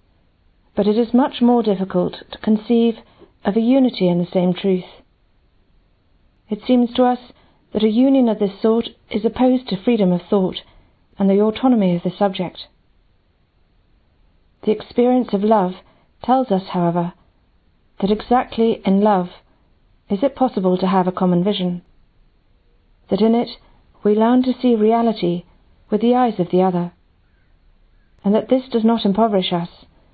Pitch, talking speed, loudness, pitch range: 205 Hz, 155 wpm, -18 LUFS, 175-230 Hz